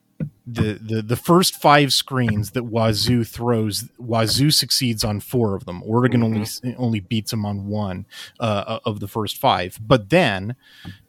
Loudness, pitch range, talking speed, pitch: -20 LUFS, 105-125 Hz, 155 wpm, 115 Hz